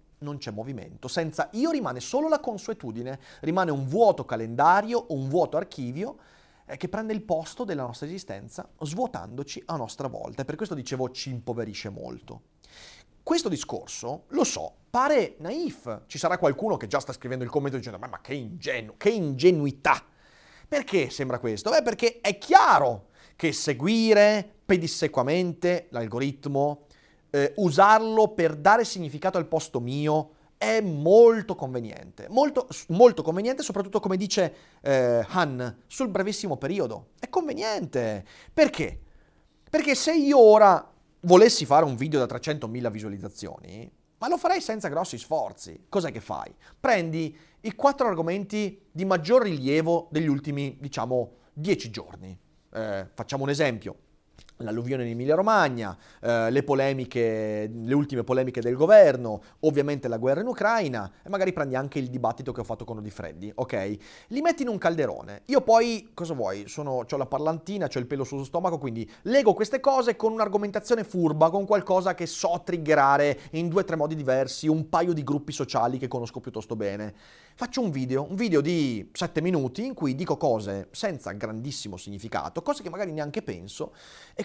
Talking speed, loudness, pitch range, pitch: 160 wpm, -25 LUFS, 130-200 Hz, 155 Hz